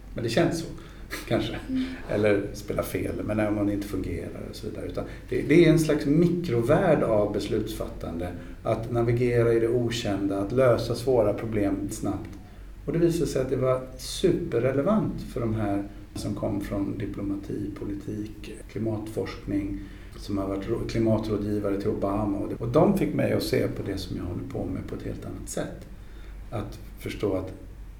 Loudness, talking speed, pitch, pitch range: -27 LUFS, 170 wpm, 105 Hz, 100-120 Hz